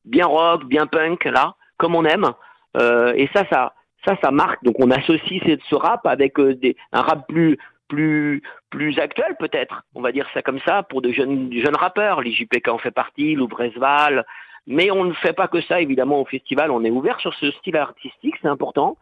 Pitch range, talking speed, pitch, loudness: 130-170 Hz, 205 wpm, 150 Hz, -19 LUFS